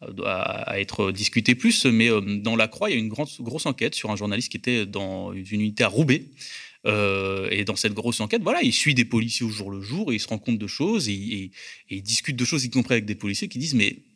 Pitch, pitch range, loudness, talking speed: 110 Hz, 100-125 Hz, -24 LUFS, 265 wpm